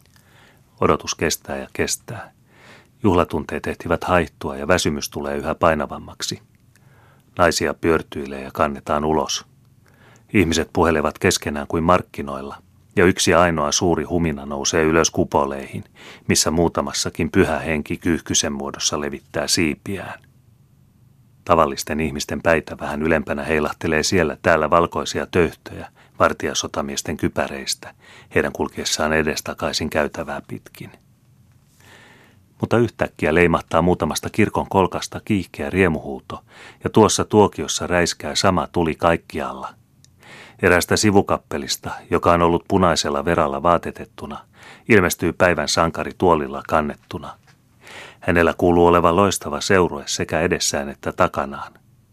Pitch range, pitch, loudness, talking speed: 75-100 Hz, 85 Hz, -20 LUFS, 105 wpm